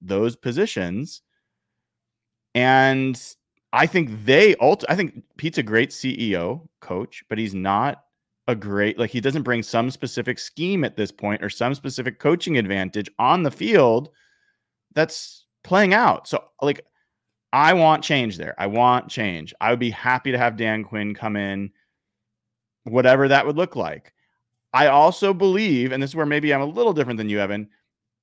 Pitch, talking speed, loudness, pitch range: 120 Hz, 170 wpm, -21 LUFS, 110-140 Hz